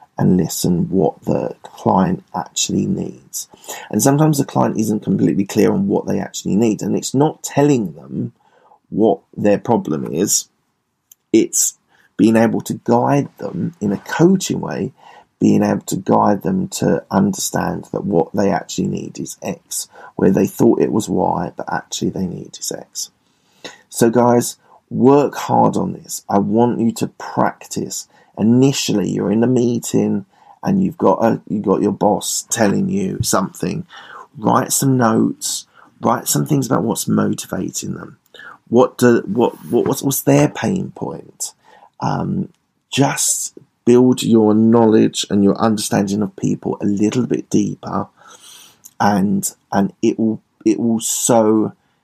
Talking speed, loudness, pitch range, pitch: 150 wpm, -17 LUFS, 105-135 Hz, 115 Hz